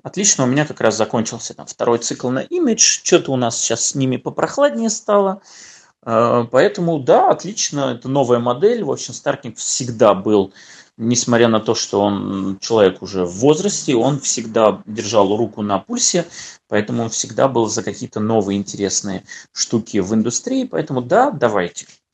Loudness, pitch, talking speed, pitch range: -17 LUFS, 120 Hz, 160 wpm, 110-155 Hz